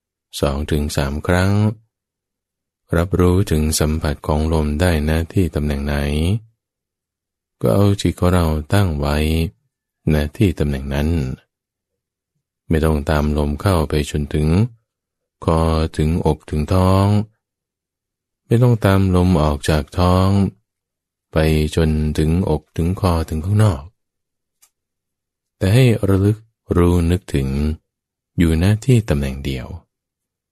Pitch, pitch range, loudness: 80 Hz, 75-95 Hz, -18 LUFS